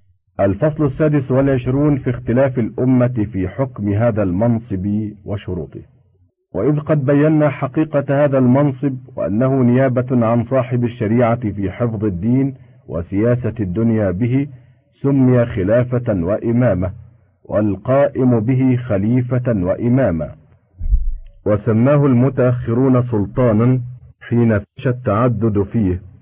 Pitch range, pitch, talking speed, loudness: 105-130 Hz, 120 Hz, 95 wpm, -17 LUFS